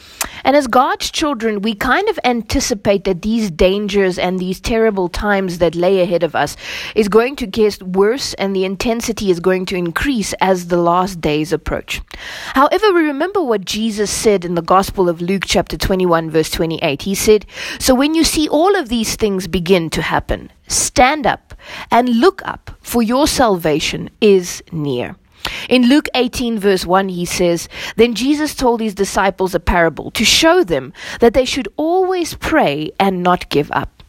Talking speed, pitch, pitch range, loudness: 180 wpm, 205 Hz, 185-245 Hz, -15 LUFS